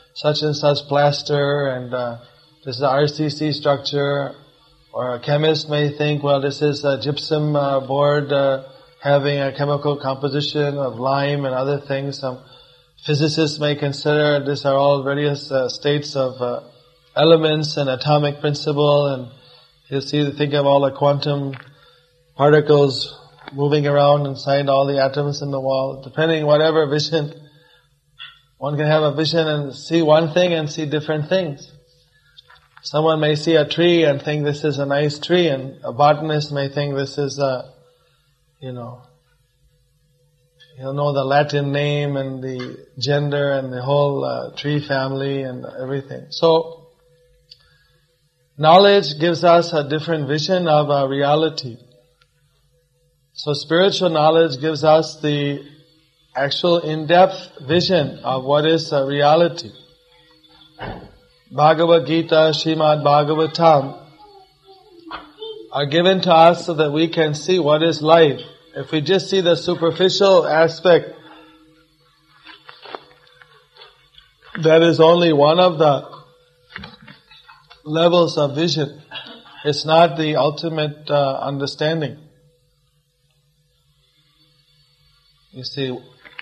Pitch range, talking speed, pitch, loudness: 140-160 Hz, 130 wpm, 150 Hz, -18 LUFS